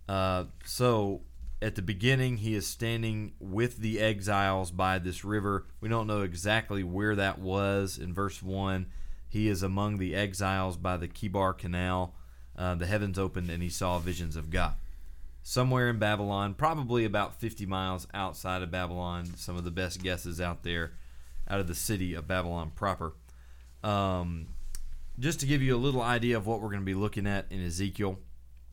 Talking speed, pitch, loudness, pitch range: 180 wpm, 95 Hz, -32 LUFS, 85-105 Hz